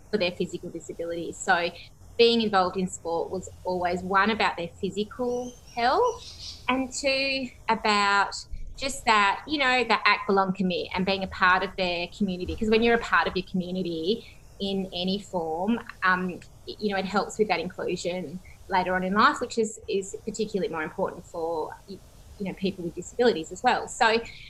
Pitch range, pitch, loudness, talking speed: 180-230 Hz, 195 Hz, -26 LUFS, 175 wpm